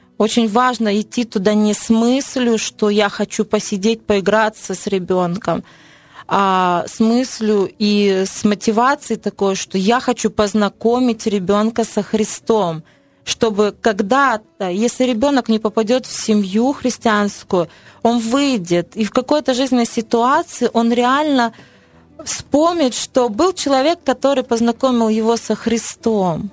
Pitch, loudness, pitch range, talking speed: 225 Hz, -17 LUFS, 210-250 Hz, 125 wpm